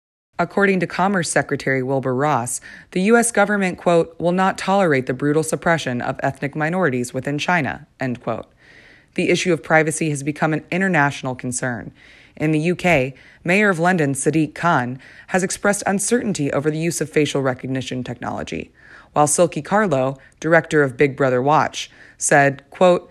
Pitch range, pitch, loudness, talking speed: 135-175 Hz, 155 Hz, -19 LUFS, 155 wpm